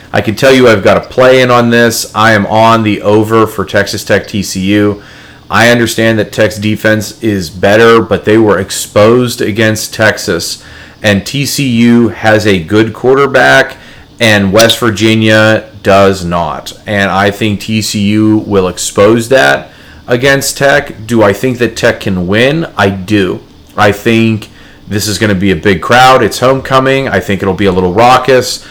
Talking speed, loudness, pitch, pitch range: 170 wpm, -8 LUFS, 110 Hz, 100-120 Hz